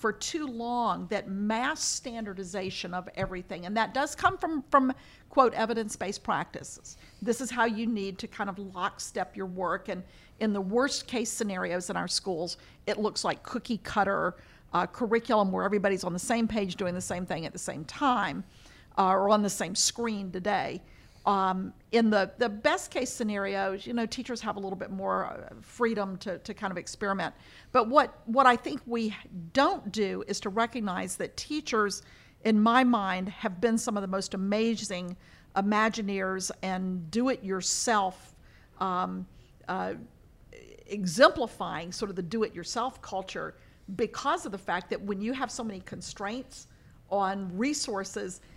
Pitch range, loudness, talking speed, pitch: 190-235 Hz, -30 LUFS, 170 wpm, 205 Hz